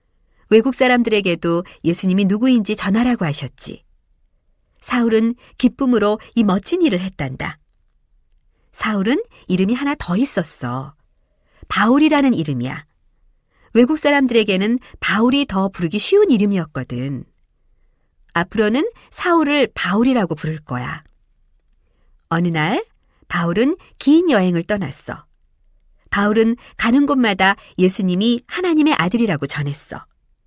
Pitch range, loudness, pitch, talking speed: 150-245 Hz, -18 LUFS, 200 Hz, 265 characters per minute